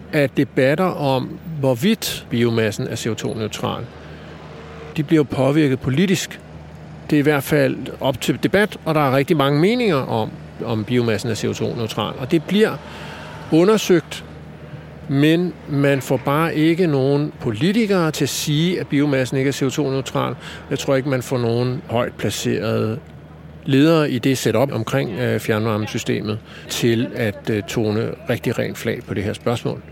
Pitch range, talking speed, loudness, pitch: 120-155 Hz, 145 wpm, -19 LUFS, 135 Hz